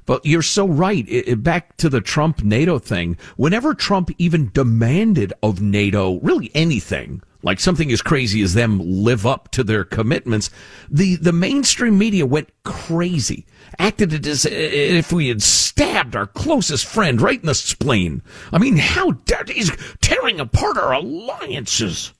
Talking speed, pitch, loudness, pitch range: 160 wpm, 150 Hz, -18 LUFS, 110-175 Hz